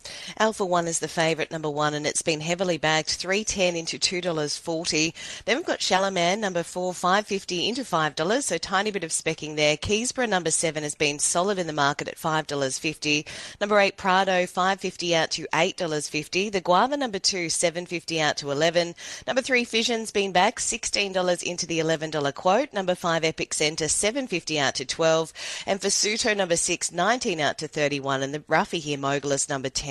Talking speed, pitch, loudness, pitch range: 185 wpm, 170 Hz, -24 LUFS, 155-190 Hz